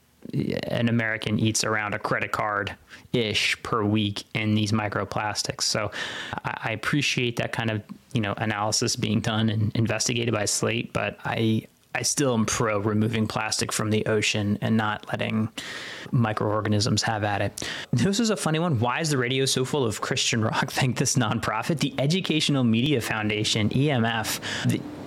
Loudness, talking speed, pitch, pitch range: -25 LUFS, 165 wpm, 110 Hz, 110-130 Hz